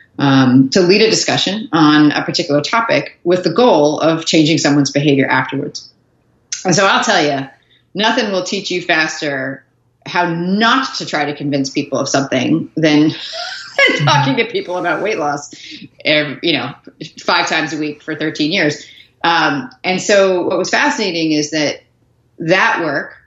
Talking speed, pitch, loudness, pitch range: 160 wpm, 155 Hz, -14 LUFS, 145-185 Hz